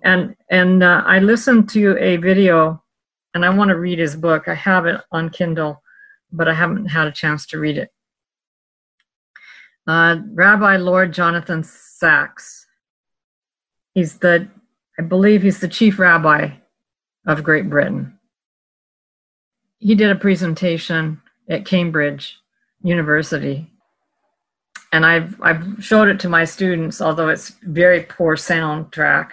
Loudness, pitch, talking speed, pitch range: -16 LUFS, 175 Hz, 135 wpm, 160-195 Hz